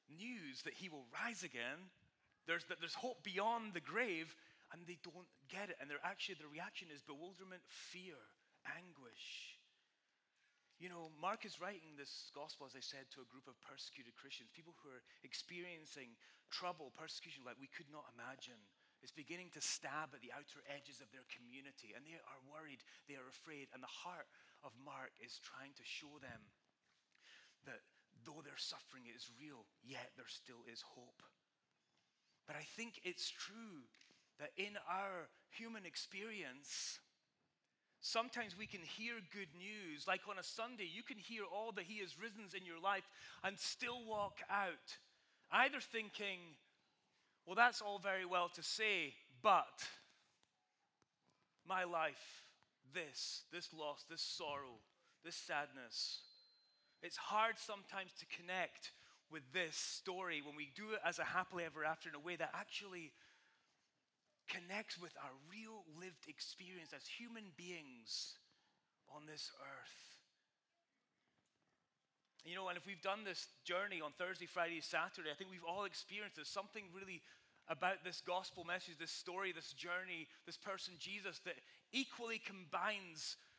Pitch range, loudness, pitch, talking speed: 150-200 Hz, -47 LUFS, 180 Hz, 155 wpm